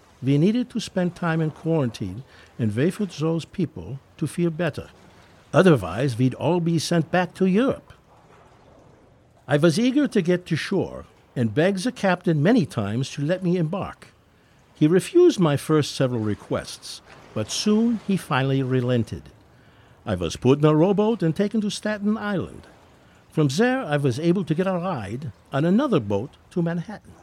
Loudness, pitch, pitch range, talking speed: -23 LUFS, 160 Hz, 125-185 Hz, 170 wpm